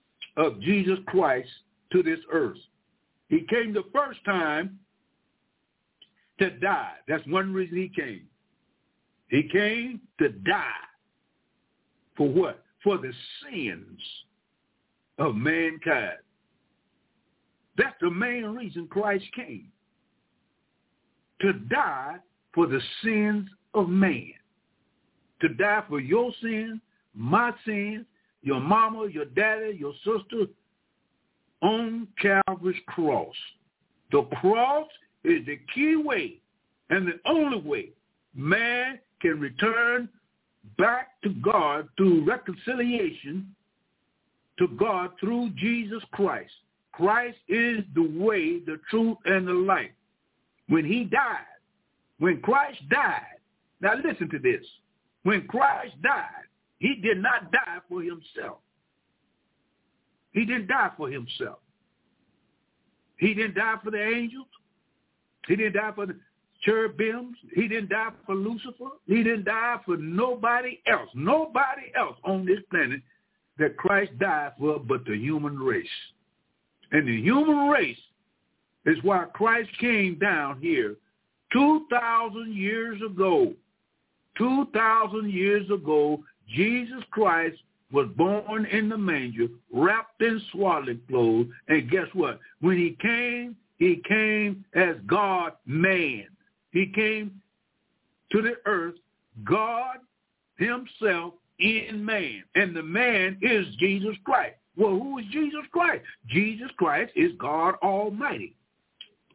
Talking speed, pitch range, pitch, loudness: 115 wpm, 185-240 Hz, 215 Hz, -26 LUFS